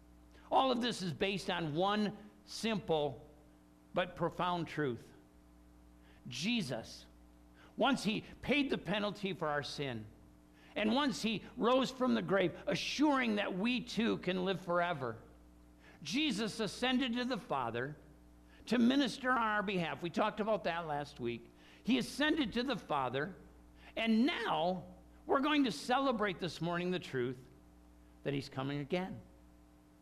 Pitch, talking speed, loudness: 175 Hz, 140 wpm, -36 LUFS